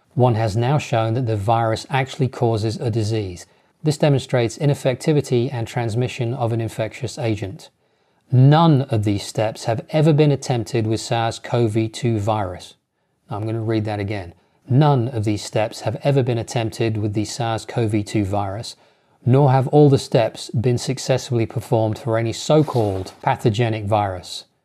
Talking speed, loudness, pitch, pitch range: 165 wpm, -20 LUFS, 115 Hz, 110-130 Hz